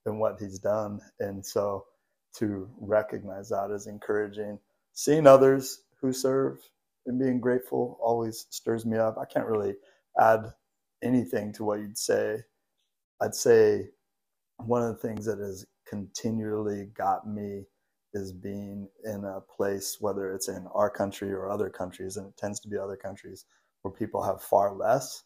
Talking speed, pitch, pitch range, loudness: 160 wpm, 105 Hz, 100-115 Hz, -28 LUFS